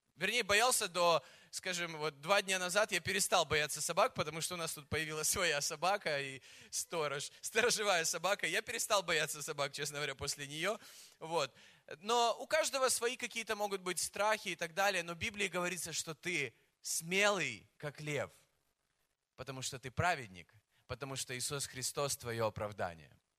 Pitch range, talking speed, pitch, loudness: 140-200 Hz, 160 wpm, 165 Hz, -35 LUFS